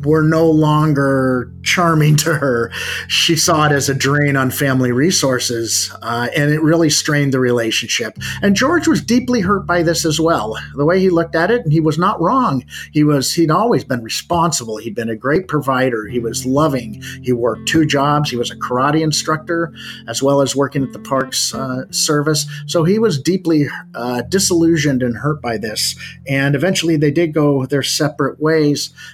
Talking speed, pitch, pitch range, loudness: 190 wpm, 150 Hz, 130-165 Hz, -15 LUFS